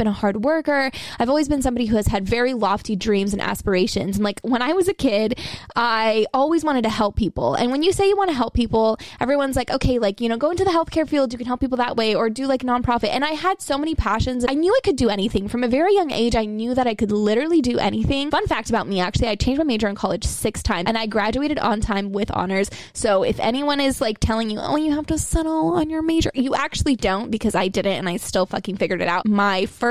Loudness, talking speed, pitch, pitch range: -21 LUFS, 275 wpm, 240 Hz, 210-290 Hz